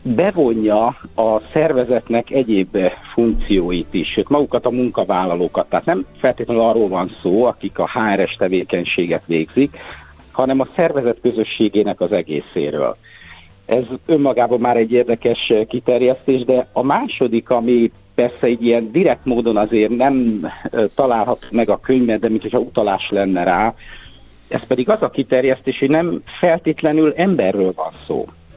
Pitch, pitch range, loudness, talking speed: 120 Hz, 110-130 Hz, -17 LUFS, 135 wpm